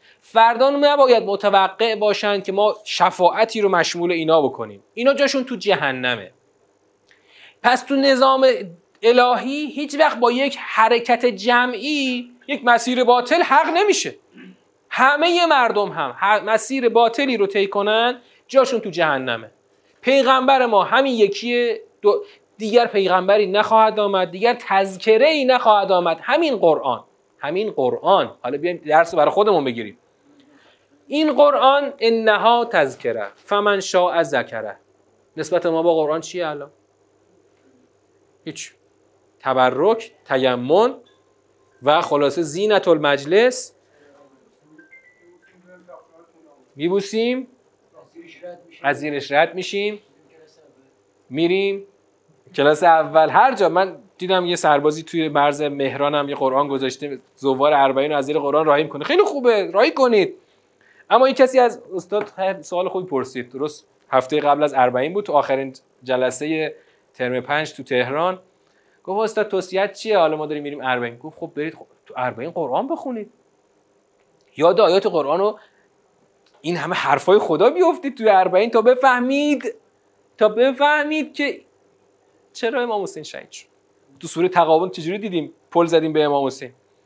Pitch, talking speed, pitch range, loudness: 205 Hz, 125 wpm, 160-265 Hz, -18 LUFS